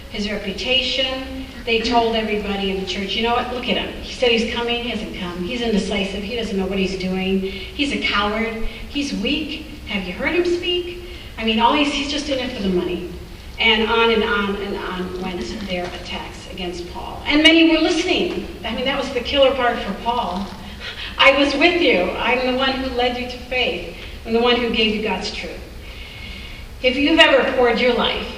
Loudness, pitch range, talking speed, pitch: -19 LUFS, 200-265 Hz, 210 wpm, 235 Hz